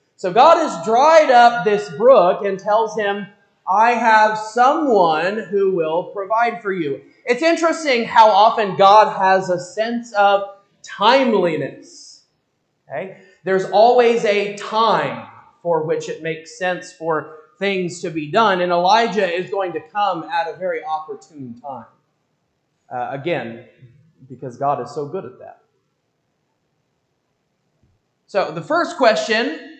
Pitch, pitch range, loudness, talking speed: 200 Hz, 175-230 Hz, -17 LUFS, 135 wpm